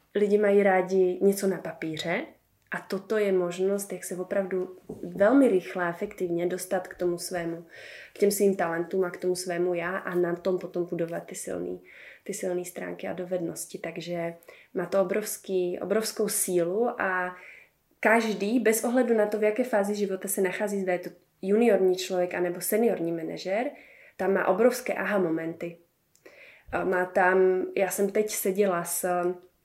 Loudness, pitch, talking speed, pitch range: -27 LUFS, 185 Hz, 165 wpm, 175-200 Hz